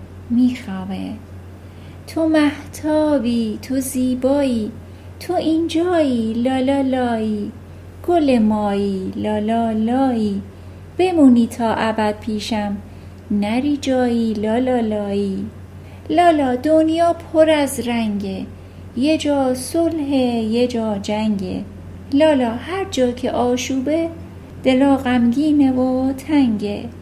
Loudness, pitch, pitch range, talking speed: -18 LUFS, 245 Hz, 215-280 Hz, 90 wpm